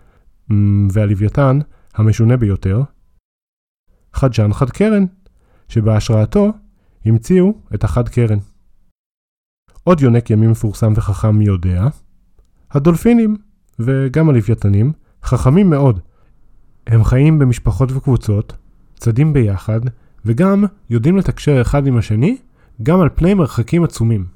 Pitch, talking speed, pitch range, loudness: 120 Hz, 95 wpm, 105-145 Hz, -15 LUFS